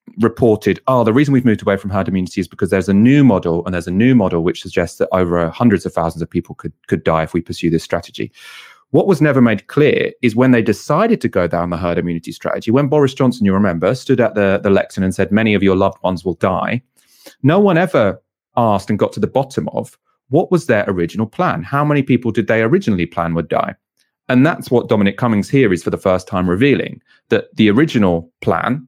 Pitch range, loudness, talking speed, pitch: 90-125 Hz, -15 LUFS, 235 wpm, 105 Hz